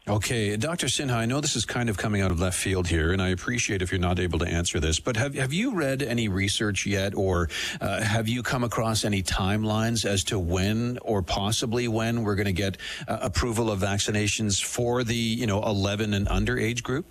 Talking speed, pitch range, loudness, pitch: 225 wpm, 95-120 Hz, -26 LUFS, 105 Hz